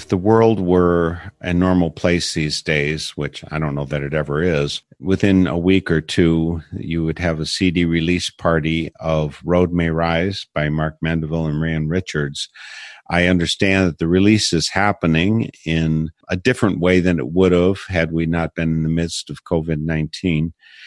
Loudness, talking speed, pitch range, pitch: -19 LUFS, 180 wpm, 80-90 Hz, 85 Hz